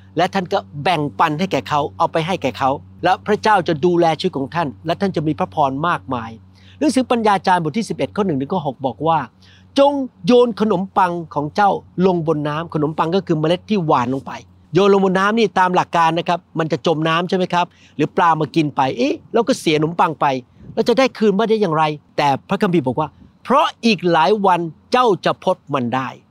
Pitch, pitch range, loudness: 170 Hz, 145-195 Hz, -18 LUFS